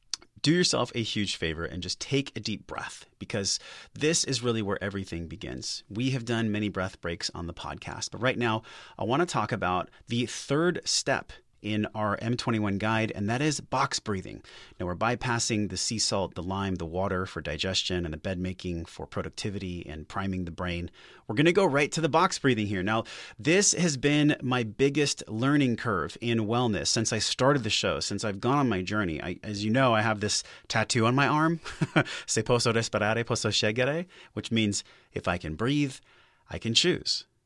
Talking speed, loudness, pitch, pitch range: 200 wpm, -28 LUFS, 110 Hz, 95-130 Hz